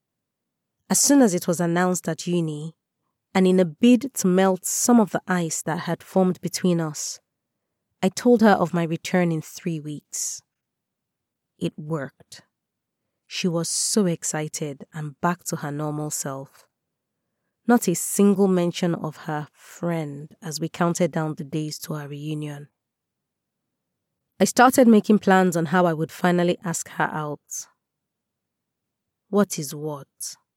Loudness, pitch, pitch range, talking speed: -22 LUFS, 170 Hz, 155-185 Hz, 145 wpm